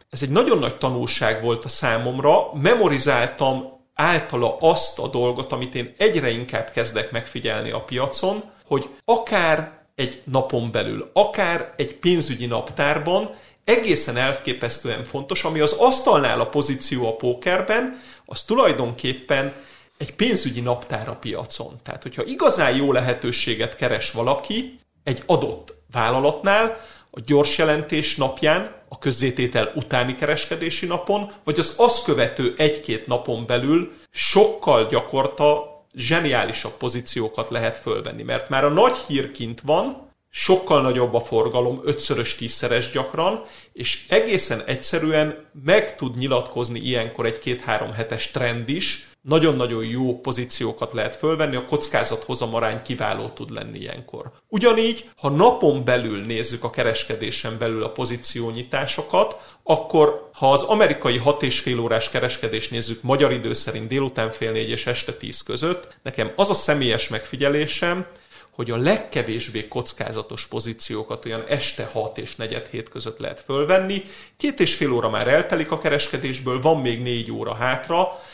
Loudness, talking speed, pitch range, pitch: -21 LUFS, 135 wpm, 120-160 Hz, 135 Hz